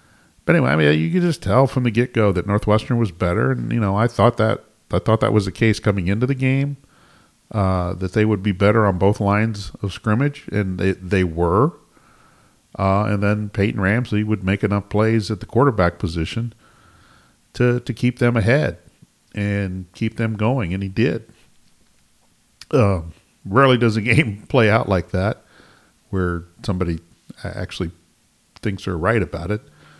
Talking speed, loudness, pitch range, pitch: 175 wpm, -20 LUFS, 95-115 Hz, 105 Hz